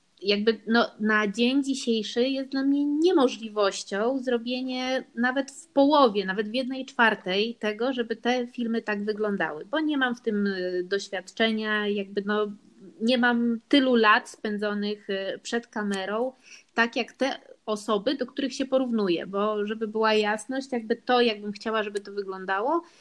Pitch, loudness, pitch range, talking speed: 230 Hz, -26 LUFS, 210-255 Hz, 150 wpm